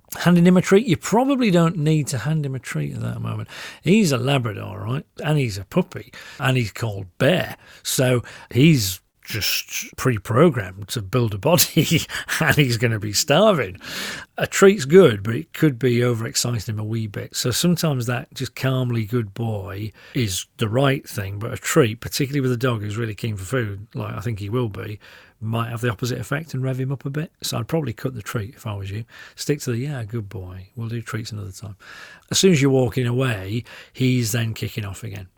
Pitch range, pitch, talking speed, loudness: 110-140 Hz, 125 Hz, 215 wpm, -21 LUFS